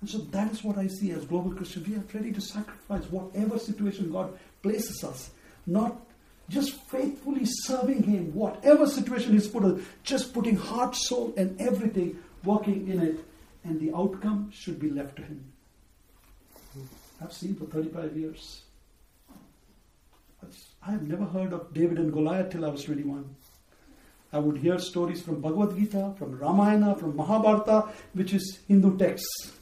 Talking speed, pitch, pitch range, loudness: 160 wpm, 195 Hz, 165-215 Hz, -28 LUFS